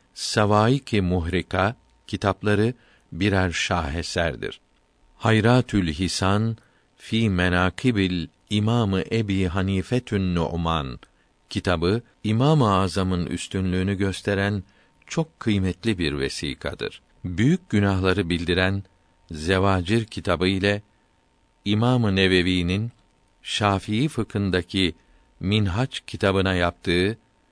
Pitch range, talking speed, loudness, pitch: 90-105 Hz, 80 wpm, -23 LUFS, 95 Hz